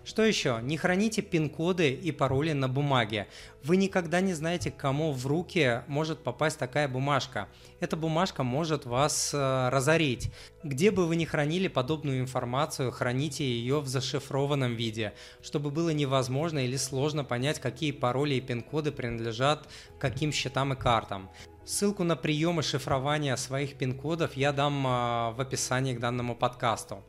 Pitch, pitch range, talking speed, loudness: 140 Hz, 125-155 Hz, 150 wpm, -29 LUFS